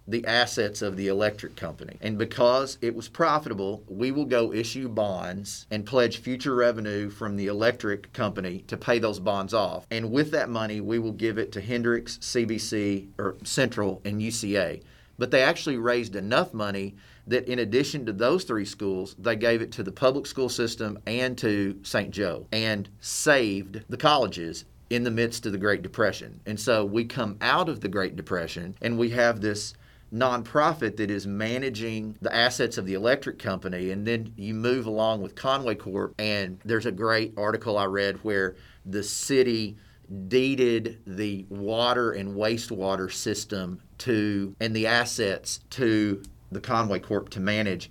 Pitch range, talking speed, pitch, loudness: 100-120 Hz, 170 wpm, 110 Hz, -27 LUFS